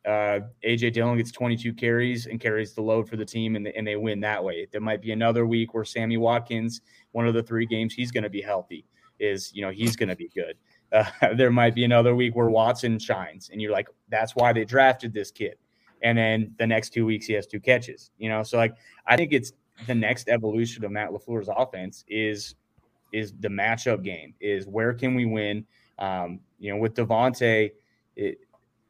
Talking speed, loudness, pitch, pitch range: 215 wpm, -25 LUFS, 115 Hz, 105-120 Hz